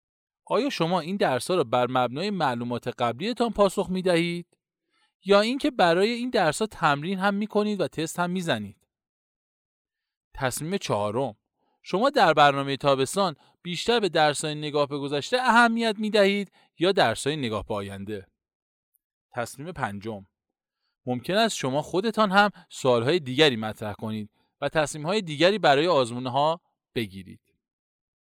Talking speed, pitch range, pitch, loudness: 140 wpm, 125-200 Hz, 155 Hz, -25 LUFS